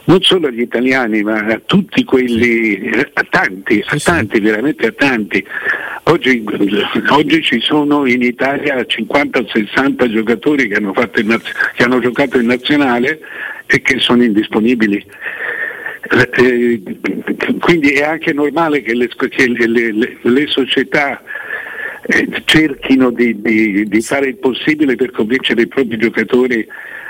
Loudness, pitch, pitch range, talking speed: -13 LUFS, 130 Hz, 115-145 Hz, 130 wpm